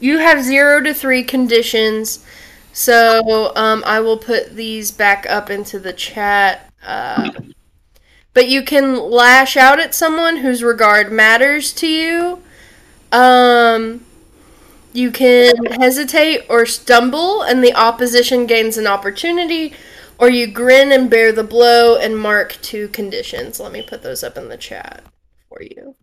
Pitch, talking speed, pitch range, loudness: 245 Hz, 145 wpm, 225-285 Hz, -12 LUFS